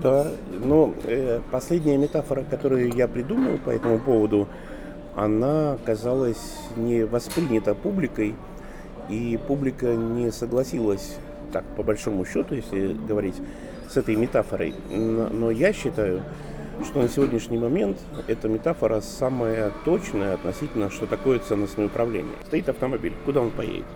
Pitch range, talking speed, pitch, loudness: 105-130 Hz, 125 wpm, 115 Hz, -25 LUFS